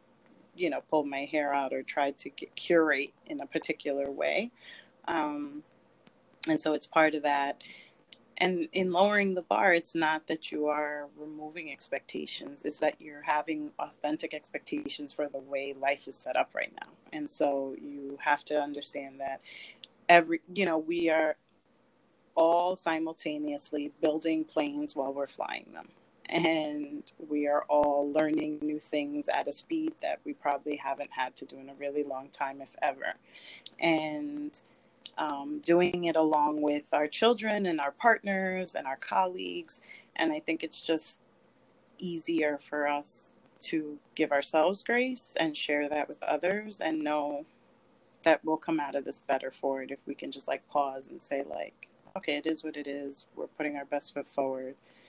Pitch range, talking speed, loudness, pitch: 145-170 Hz, 170 wpm, -31 LUFS, 150 Hz